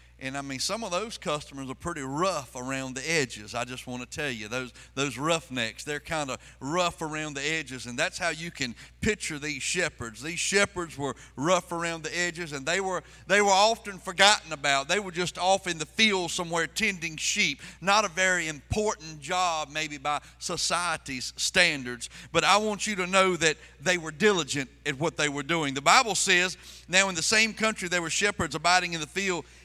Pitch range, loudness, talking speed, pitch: 145-185 Hz, -27 LUFS, 205 wpm, 165 Hz